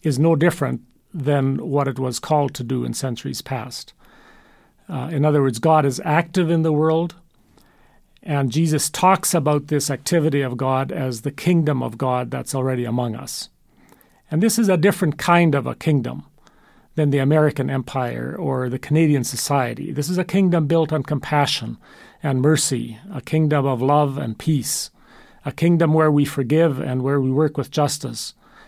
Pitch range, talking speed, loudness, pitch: 130-160 Hz, 175 wpm, -20 LUFS, 145 Hz